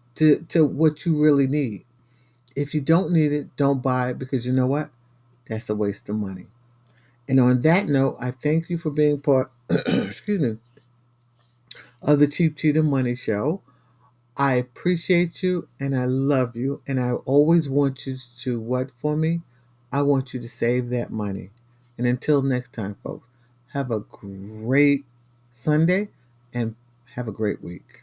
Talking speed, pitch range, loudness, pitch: 165 wpm, 120-145 Hz, -23 LUFS, 130 Hz